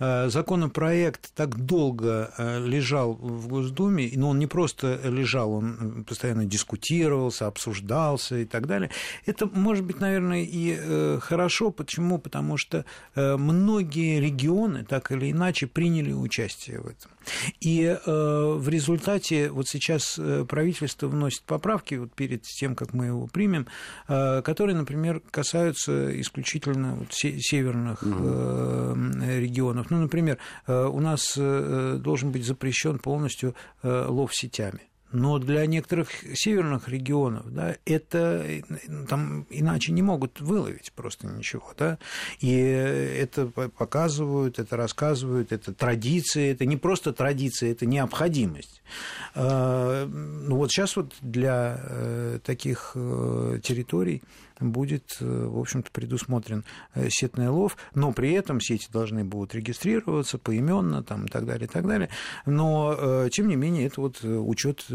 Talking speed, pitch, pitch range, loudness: 120 wpm, 135 Hz, 120-160 Hz, -27 LUFS